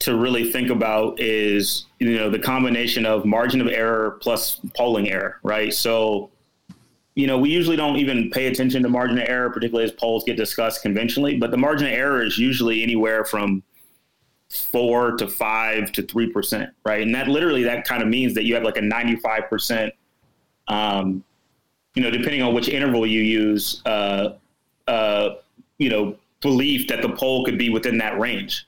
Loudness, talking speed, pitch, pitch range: -21 LUFS, 185 wpm, 115 Hz, 110-125 Hz